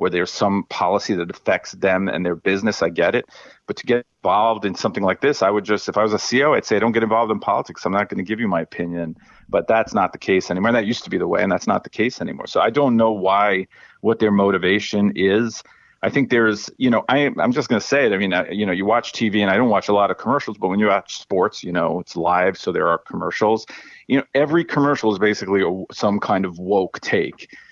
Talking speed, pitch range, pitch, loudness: 270 wpm, 100-115 Hz, 105 Hz, -19 LUFS